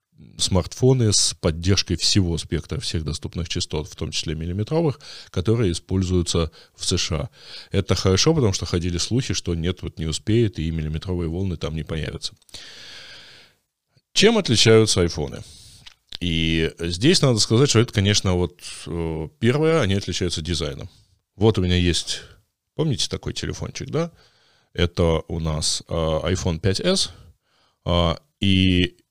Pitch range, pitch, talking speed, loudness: 85-110 Hz, 90 Hz, 130 wpm, -22 LUFS